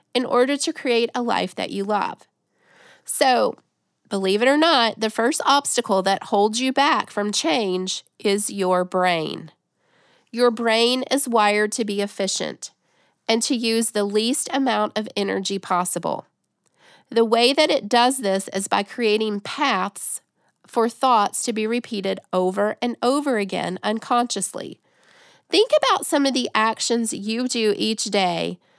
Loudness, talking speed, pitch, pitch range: -21 LUFS, 150 wpm, 225 Hz, 205-250 Hz